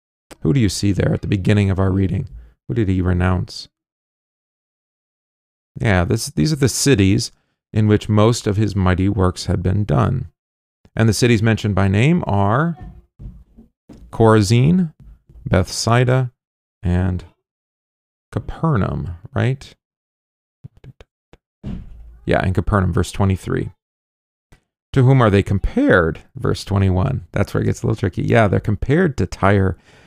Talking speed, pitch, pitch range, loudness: 135 wpm, 100 Hz, 90-115 Hz, -18 LUFS